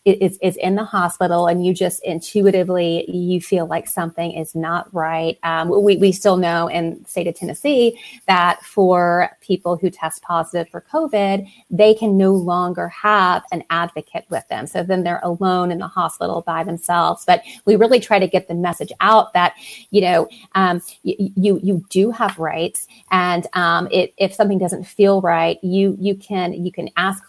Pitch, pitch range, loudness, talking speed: 180 Hz, 170-195 Hz, -18 LUFS, 185 wpm